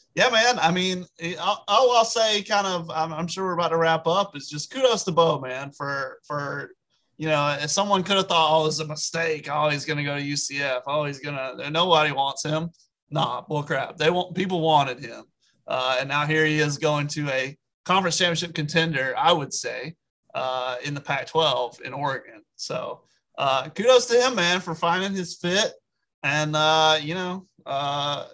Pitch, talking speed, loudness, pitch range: 155 Hz, 200 wpm, -23 LUFS, 145-180 Hz